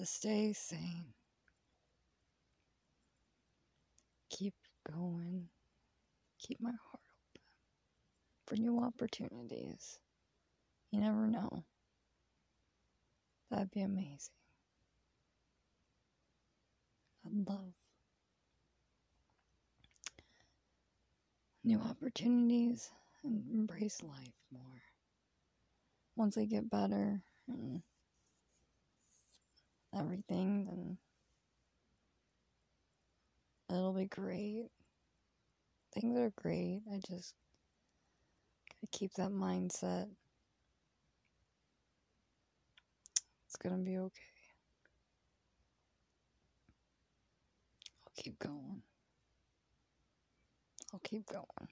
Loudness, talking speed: -41 LUFS, 65 wpm